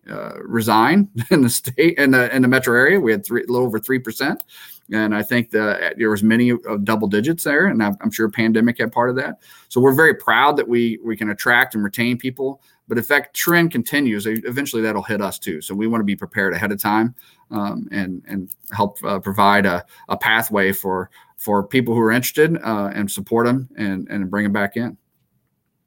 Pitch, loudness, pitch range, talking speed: 110 Hz, -18 LUFS, 105-120 Hz, 215 wpm